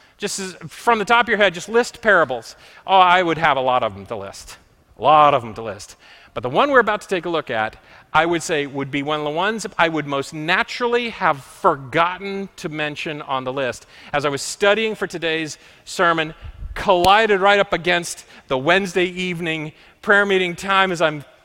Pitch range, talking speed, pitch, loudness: 150-195 Hz, 210 wpm, 170 Hz, -19 LUFS